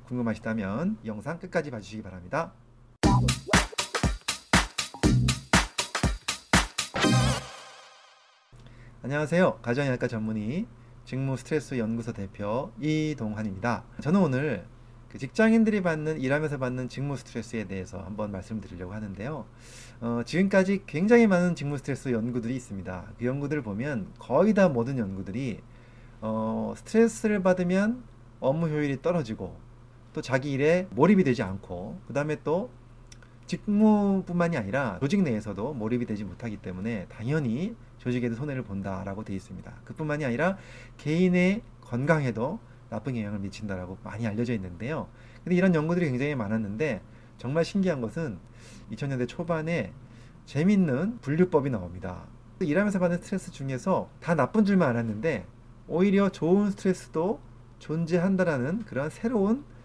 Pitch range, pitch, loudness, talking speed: 115-165 Hz, 125 Hz, -28 LUFS, 325 characters per minute